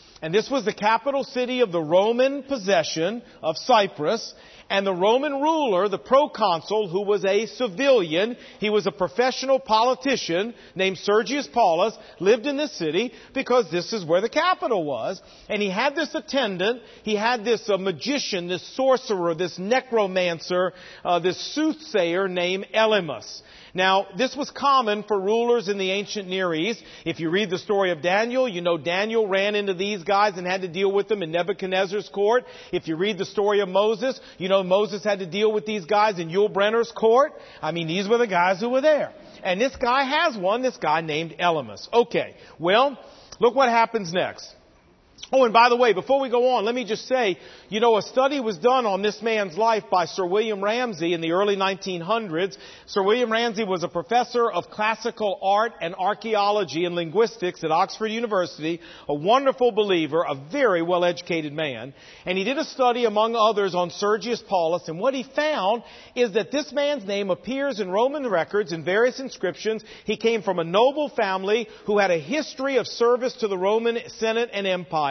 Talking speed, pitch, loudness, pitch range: 190 wpm, 210 Hz, -23 LUFS, 185-240 Hz